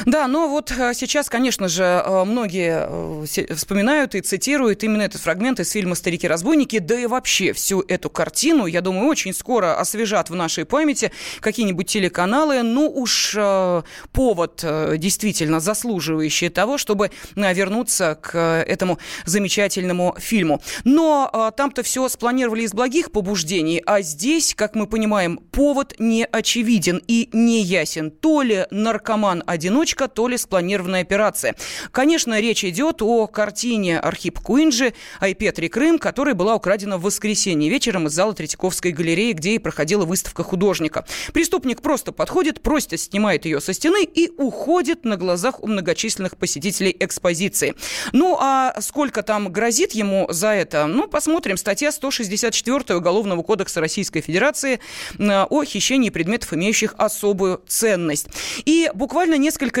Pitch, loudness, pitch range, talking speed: 210 Hz, -19 LUFS, 185-255 Hz, 135 wpm